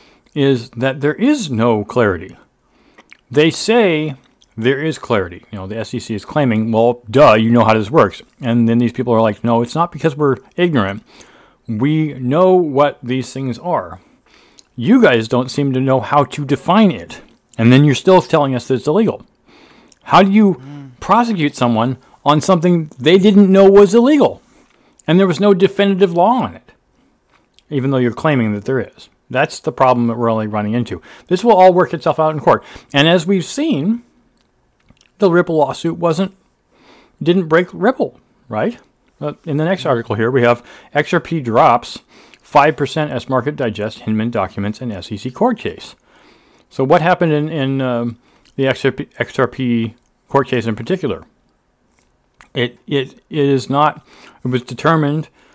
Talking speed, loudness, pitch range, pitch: 170 wpm, -15 LUFS, 120-175 Hz, 140 Hz